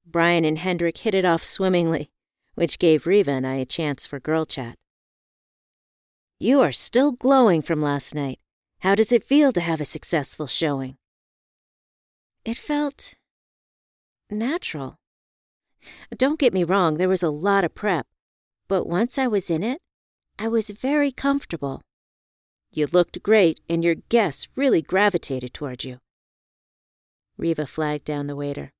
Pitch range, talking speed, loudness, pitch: 145-215 Hz, 150 wpm, -22 LUFS, 165 Hz